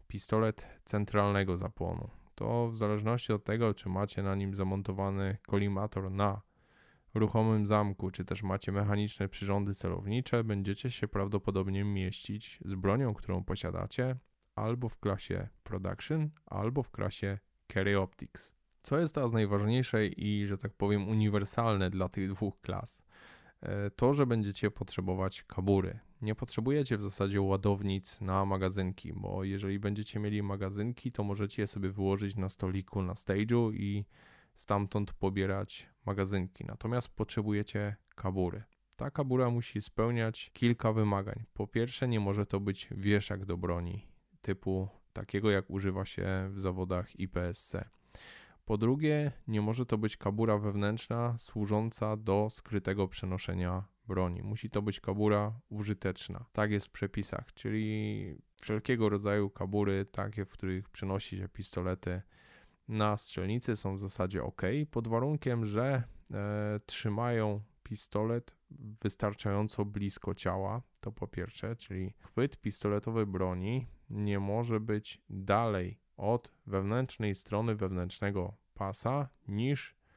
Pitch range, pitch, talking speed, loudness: 95-110 Hz, 105 Hz, 130 wpm, -34 LUFS